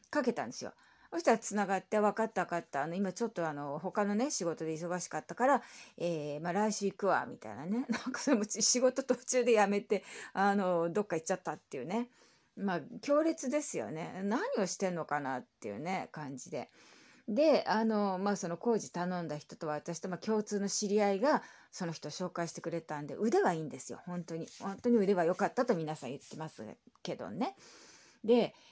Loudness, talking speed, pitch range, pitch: -34 LUFS, 385 characters per minute, 170-235 Hz, 200 Hz